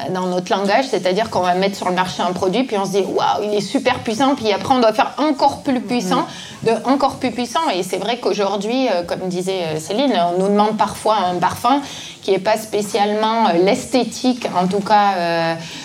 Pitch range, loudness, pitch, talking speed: 185-240 Hz, -18 LUFS, 205 Hz, 205 wpm